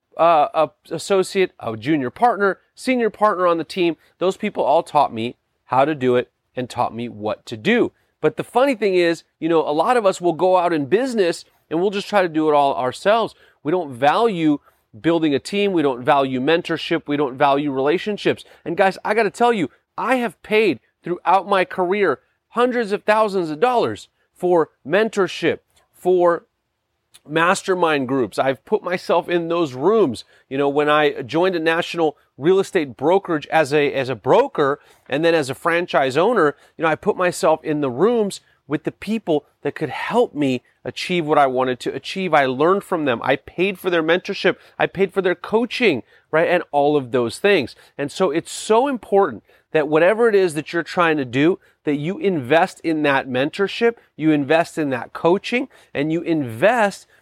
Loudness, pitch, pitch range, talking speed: -19 LUFS, 165 Hz, 145-195 Hz, 195 wpm